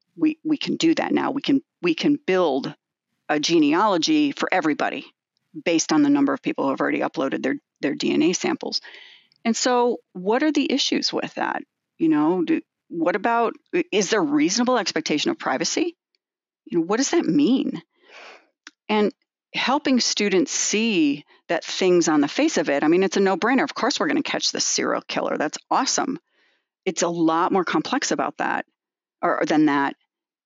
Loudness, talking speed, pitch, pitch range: -22 LUFS, 180 wpm, 285 Hz, 205-315 Hz